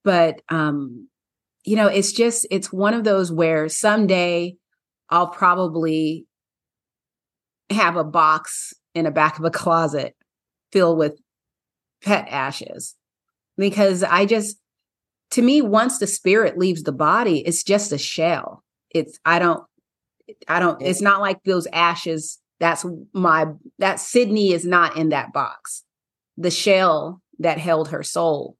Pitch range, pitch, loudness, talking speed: 160-200 Hz, 175 Hz, -19 LUFS, 135 wpm